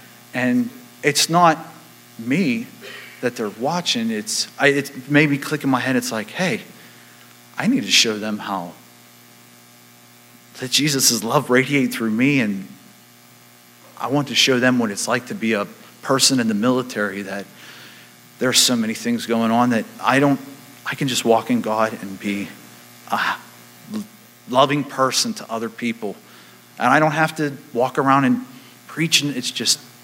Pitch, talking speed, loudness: 120 Hz, 160 wpm, -19 LUFS